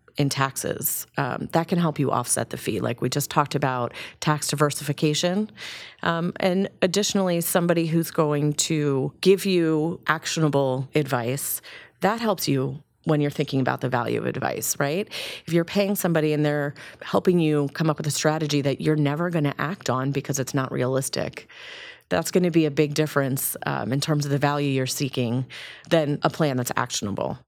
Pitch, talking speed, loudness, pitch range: 150 Hz, 185 wpm, -24 LUFS, 140-170 Hz